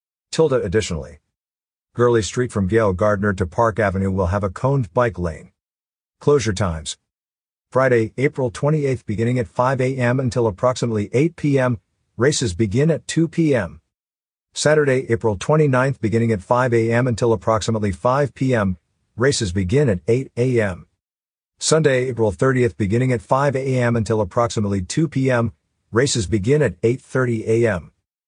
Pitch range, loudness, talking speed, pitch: 105-130 Hz, -19 LUFS, 140 wpm, 115 Hz